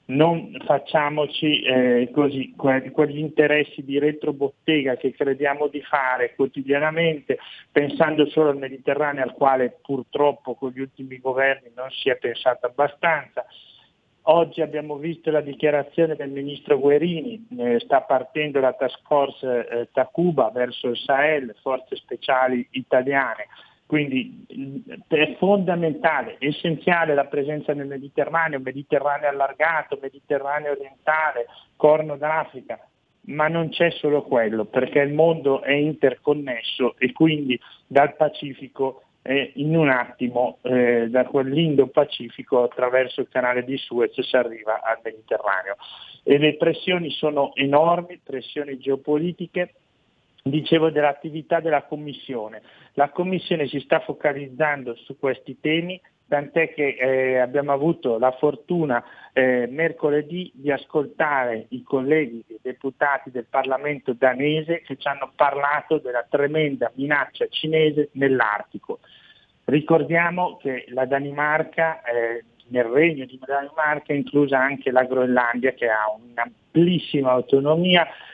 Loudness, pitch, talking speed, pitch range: -22 LUFS, 145 Hz, 125 wpm, 130-155 Hz